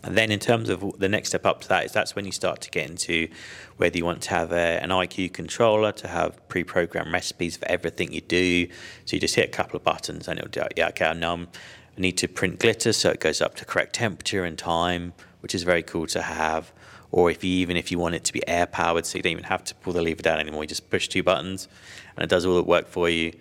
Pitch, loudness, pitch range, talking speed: 90 Hz, -25 LUFS, 85-95 Hz, 270 wpm